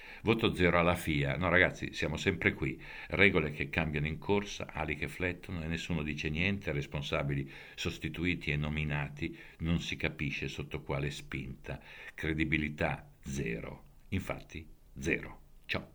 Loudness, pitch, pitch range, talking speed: -33 LUFS, 80 Hz, 75-90 Hz, 135 wpm